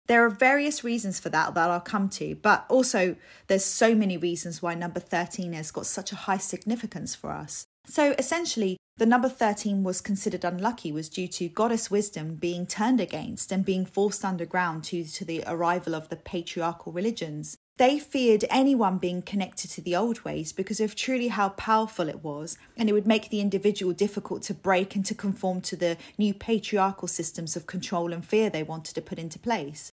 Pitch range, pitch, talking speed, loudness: 175-220 Hz, 190 Hz, 200 wpm, -27 LUFS